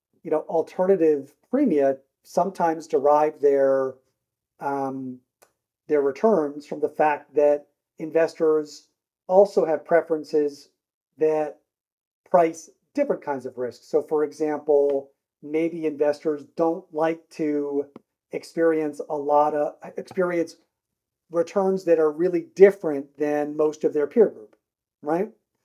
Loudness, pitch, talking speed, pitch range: -23 LUFS, 155 Hz, 115 wpm, 145-165 Hz